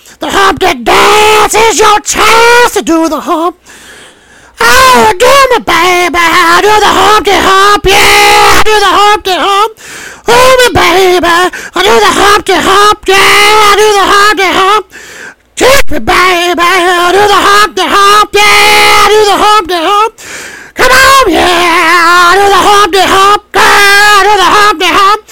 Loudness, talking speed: -4 LUFS, 160 wpm